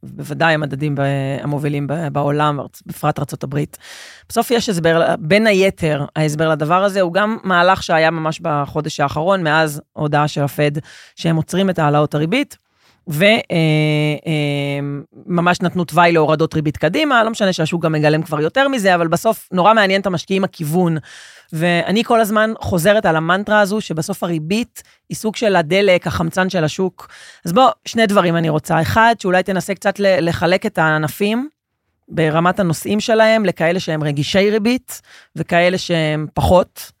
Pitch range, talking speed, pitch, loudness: 155-195 Hz, 150 wpm, 170 Hz, -16 LUFS